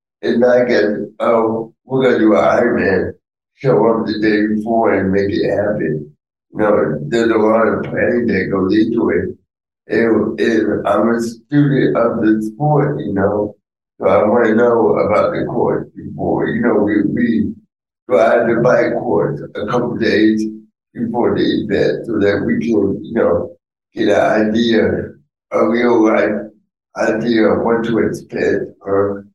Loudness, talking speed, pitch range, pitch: -15 LUFS, 165 wpm, 105-115 Hz, 110 Hz